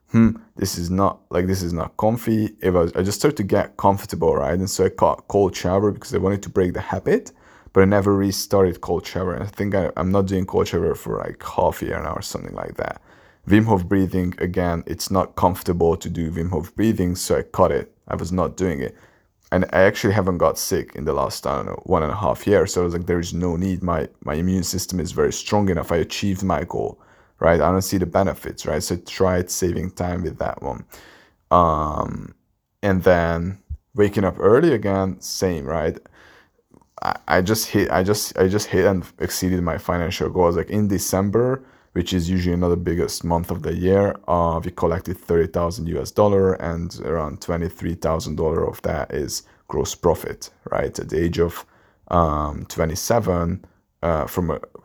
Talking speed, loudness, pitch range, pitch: 205 wpm, -21 LUFS, 85-100 Hz, 90 Hz